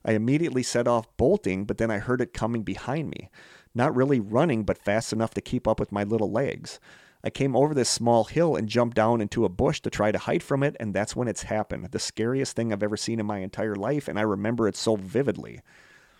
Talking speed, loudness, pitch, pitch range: 240 wpm, -26 LUFS, 115 Hz, 105-125 Hz